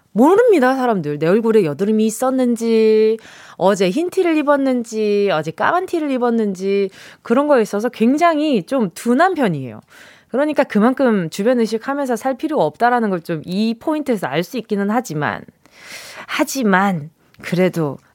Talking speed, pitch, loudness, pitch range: 325 characters per minute, 230 Hz, -17 LUFS, 200-265 Hz